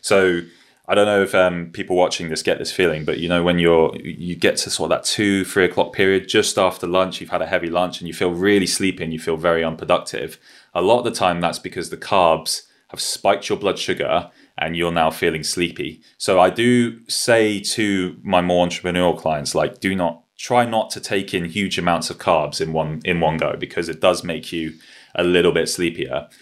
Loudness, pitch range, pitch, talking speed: -19 LUFS, 85-100 Hz, 90 Hz, 225 wpm